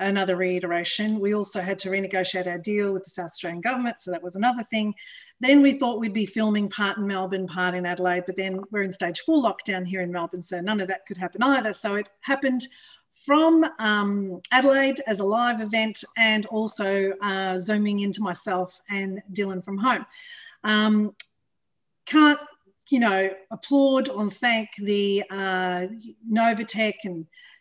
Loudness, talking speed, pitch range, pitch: -24 LUFS, 170 wpm, 190-230 Hz, 205 Hz